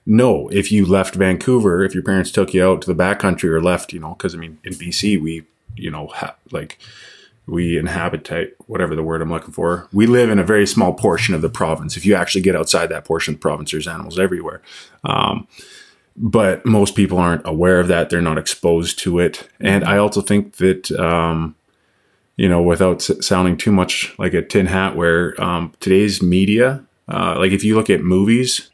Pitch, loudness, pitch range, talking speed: 95 Hz, -17 LUFS, 85-100 Hz, 215 wpm